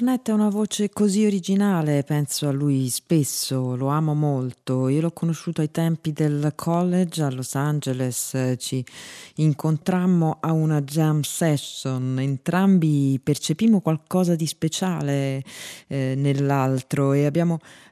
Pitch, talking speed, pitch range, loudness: 150 Hz, 125 wpm, 135-170 Hz, -23 LUFS